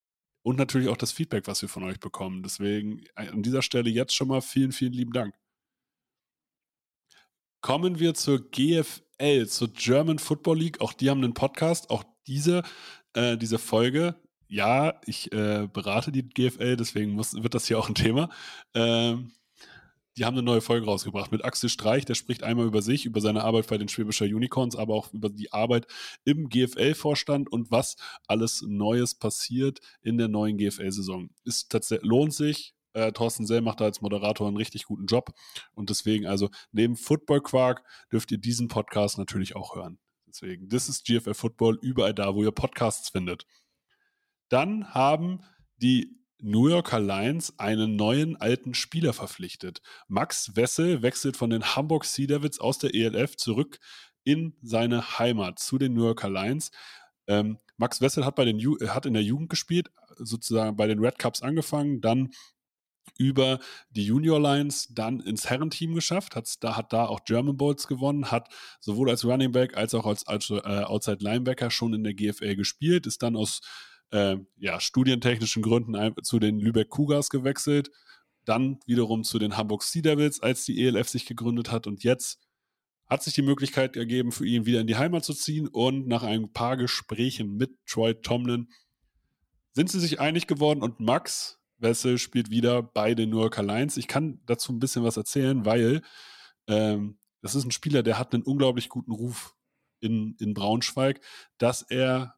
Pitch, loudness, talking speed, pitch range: 120 Hz, -27 LUFS, 175 wpm, 110-135 Hz